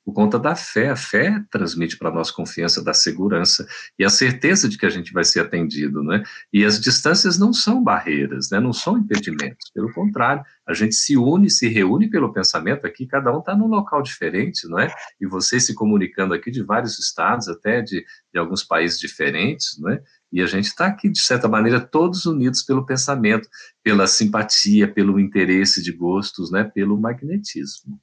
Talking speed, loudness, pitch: 195 wpm, -18 LUFS, 115 Hz